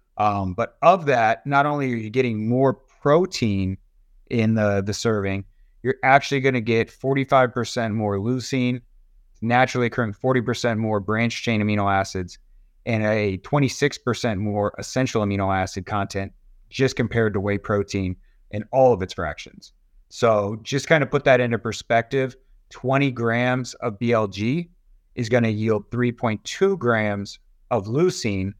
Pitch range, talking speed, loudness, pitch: 100-125 Hz, 145 wpm, -22 LUFS, 115 Hz